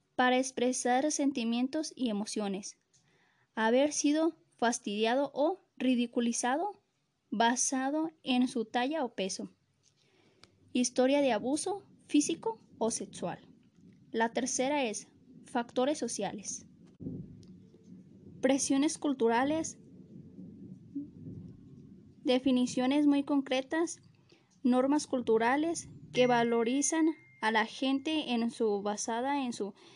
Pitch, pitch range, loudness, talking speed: 255 Hz, 230-285 Hz, -31 LUFS, 90 wpm